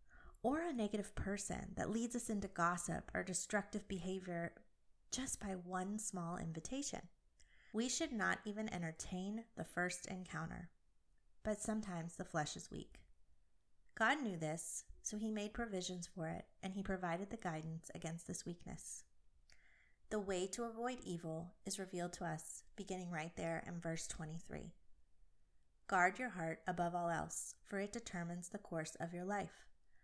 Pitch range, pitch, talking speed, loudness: 165-210 Hz, 180 Hz, 155 wpm, -44 LUFS